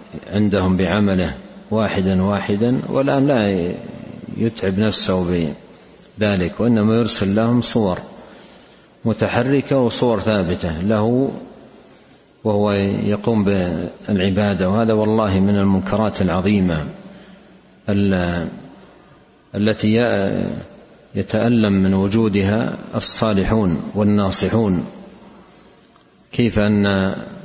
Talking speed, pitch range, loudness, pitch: 70 wpm, 95-115 Hz, -18 LUFS, 105 Hz